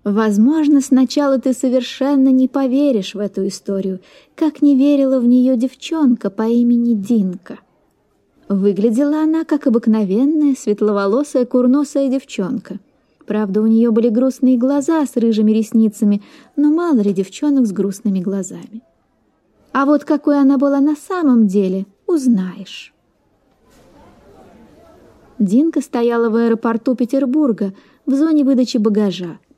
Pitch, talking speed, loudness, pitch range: 250 Hz, 120 wpm, -16 LUFS, 215-280 Hz